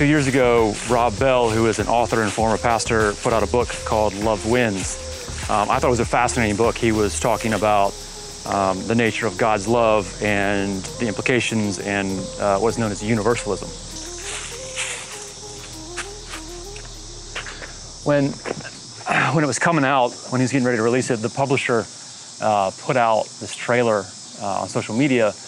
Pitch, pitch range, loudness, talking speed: 115 Hz, 105-120 Hz, -20 LUFS, 165 wpm